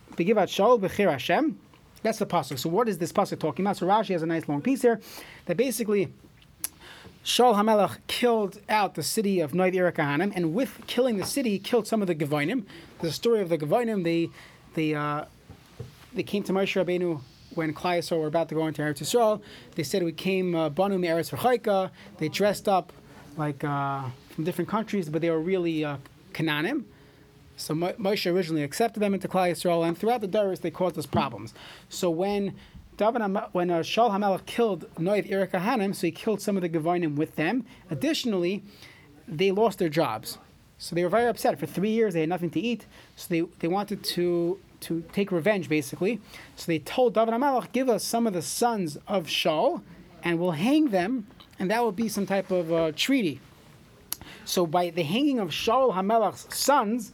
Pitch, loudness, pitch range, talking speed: 185 Hz, -26 LUFS, 165-215 Hz, 185 wpm